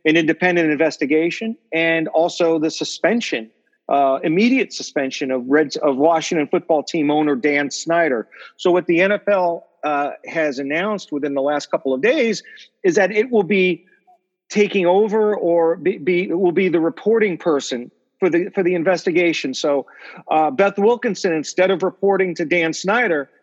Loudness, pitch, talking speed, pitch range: -18 LUFS, 170 Hz, 155 wpm, 155-195 Hz